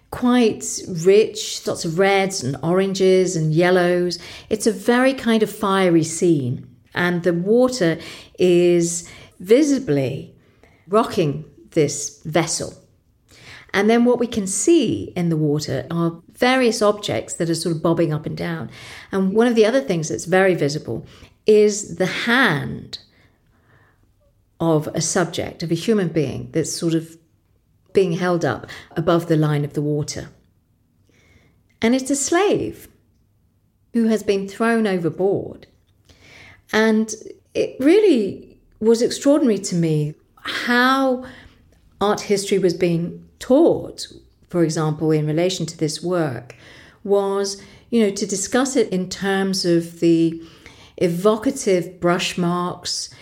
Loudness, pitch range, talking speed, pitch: -19 LUFS, 160-215 Hz, 130 wpm, 180 Hz